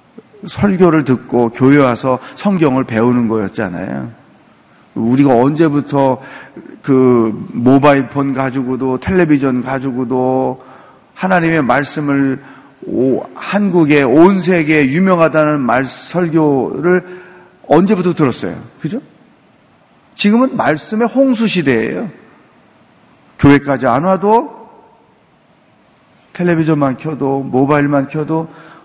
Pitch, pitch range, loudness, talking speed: 145 Hz, 130-175 Hz, -13 LUFS, 230 characters per minute